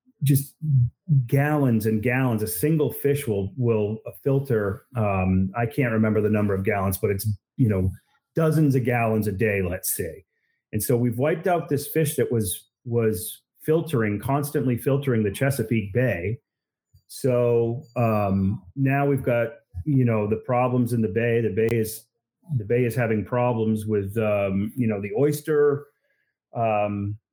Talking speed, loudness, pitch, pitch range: 160 wpm, -24 LUFS, 120 Hz, 110-140 Hz